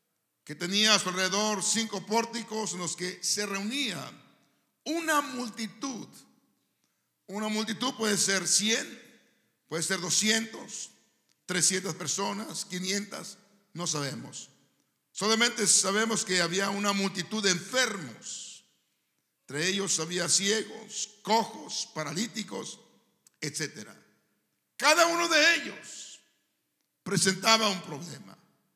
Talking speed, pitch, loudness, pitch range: 100 wpm, 205 Hz, -27 LUFS, 185-225 Hz